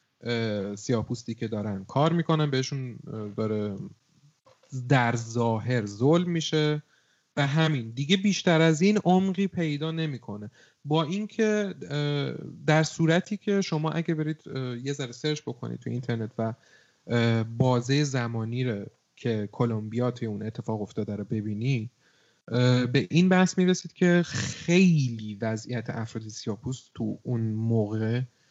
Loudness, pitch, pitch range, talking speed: -27 LUFS, 130 Hz, 115-160 Hz, 120 wpm